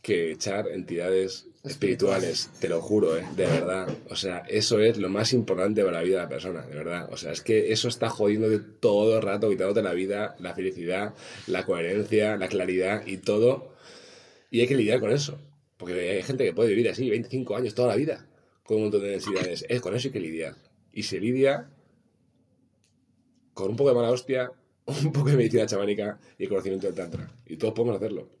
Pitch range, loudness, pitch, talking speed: 100-130 Hz, -26 LUFS, 110 Hz, 210 wpm